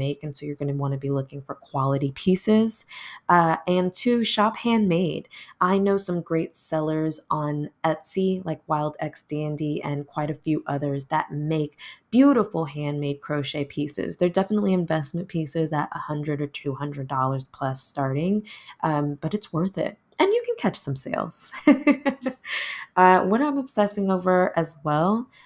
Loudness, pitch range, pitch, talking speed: -24 LUFS, 145-195 Hz, 160 Hz, 165 wpm